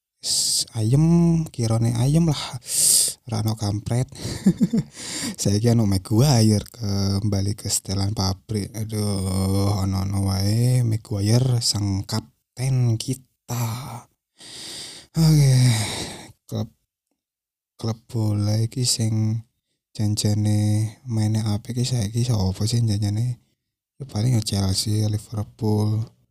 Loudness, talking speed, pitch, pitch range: -22 LUFS, 100 wpm, 110 Hz, 105-120 Hz